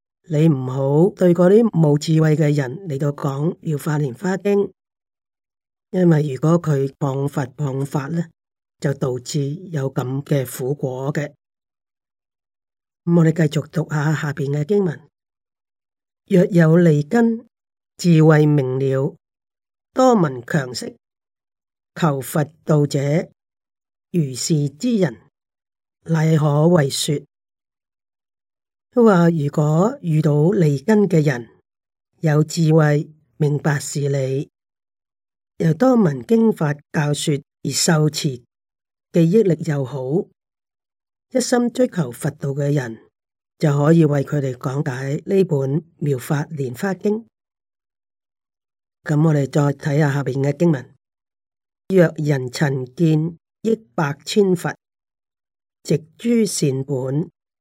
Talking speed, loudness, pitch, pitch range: 160 characters per minute, -19 LUFS, 150 Hz, 140-170 Hz